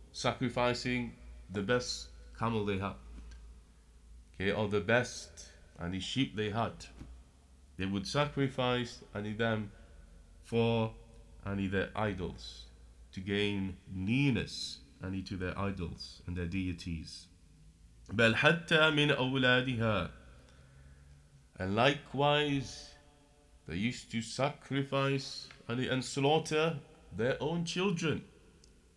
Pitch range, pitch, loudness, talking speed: 80-125 Hz, 100 Hz, -33 LUFS, 90 wpm